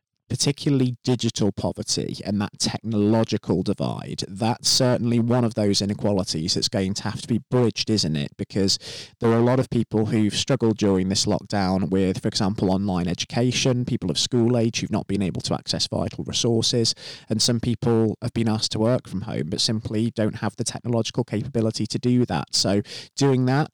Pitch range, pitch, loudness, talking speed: 100-120 Hz, 110 Hz, -23 LUFS, 185 wpm